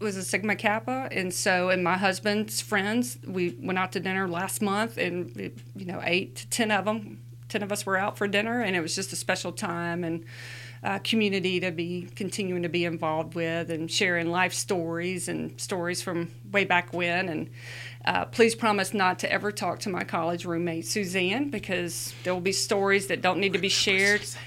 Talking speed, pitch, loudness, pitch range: 205 wpm, 185 Hz, -27 LUFS, 170-200 Hz